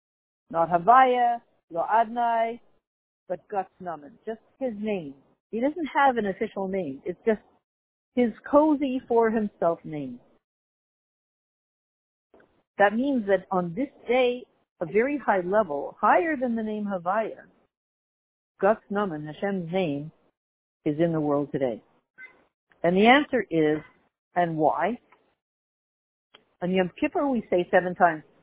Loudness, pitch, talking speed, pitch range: -25 LUFS, 205 Hz, 115 wpm, 175-240 Hz